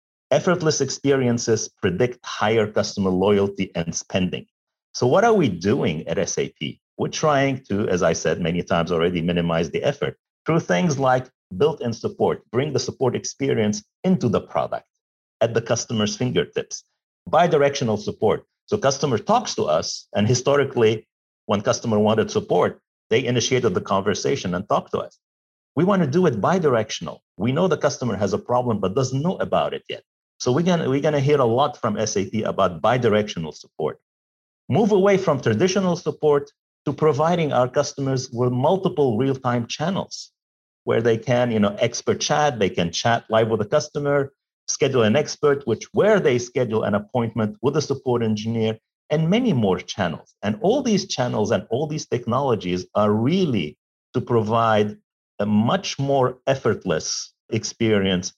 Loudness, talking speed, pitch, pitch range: -21 LUFS, 160 wpm, 125 Hz, 105-150 Hz